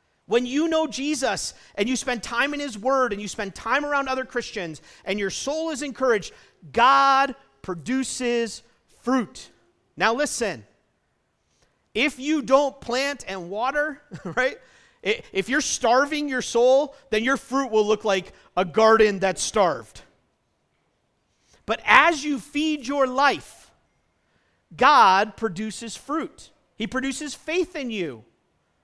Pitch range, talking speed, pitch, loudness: 215-285 Hz, 135 wpm, 260 Hz, -23 LUFS